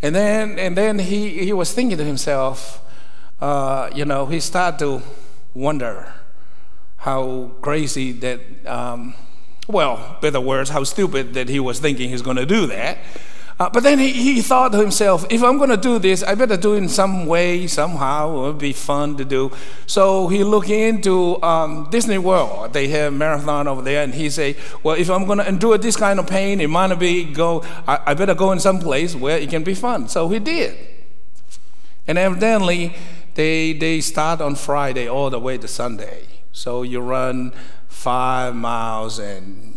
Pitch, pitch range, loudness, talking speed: 155 Hz, 135-190 Hz, -19 LUFS, 190 wpm